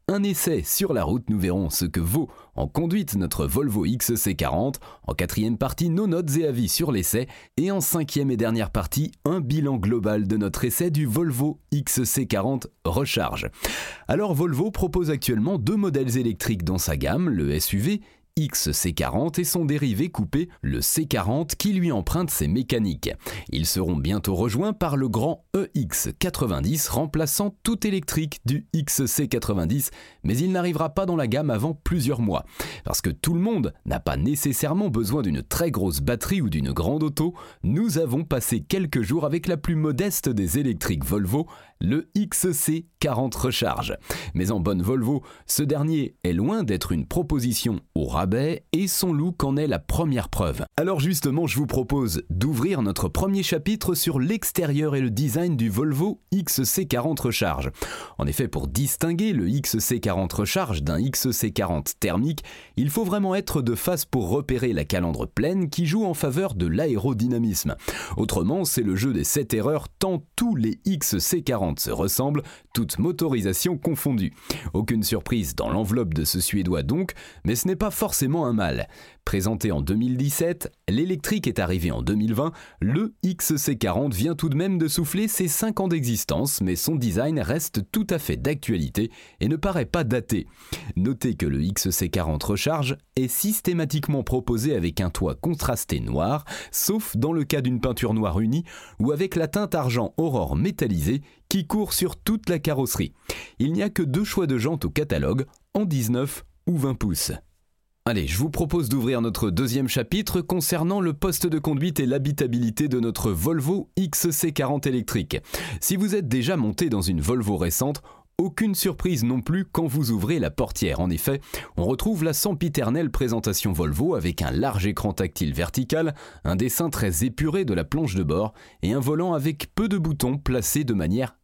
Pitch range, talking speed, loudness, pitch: 110-170 Hz, 170 wpm, -24 LUFS, 140 Hz